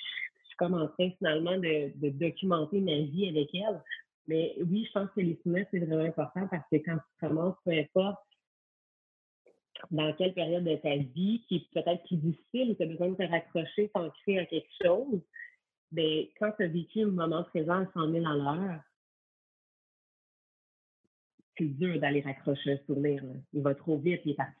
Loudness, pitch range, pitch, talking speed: -32 LUFS, 155-190 Hz, 170 Hz, 180 wpm